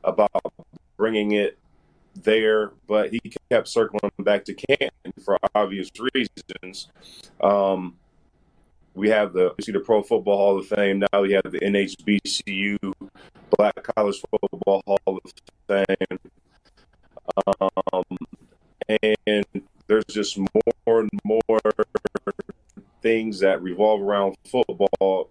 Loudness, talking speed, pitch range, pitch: -23 LUFS, 115 wpm, 95-110 Hz, 100 Hz